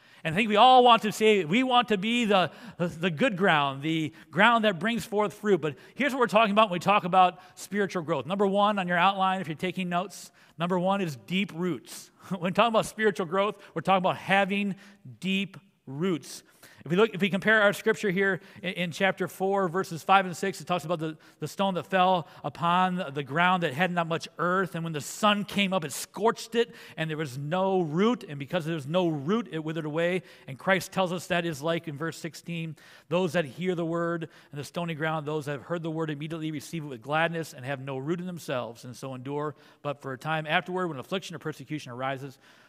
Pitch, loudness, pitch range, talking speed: 180 Hz, -27 LUFS, 160-195 Hz, 230 wpm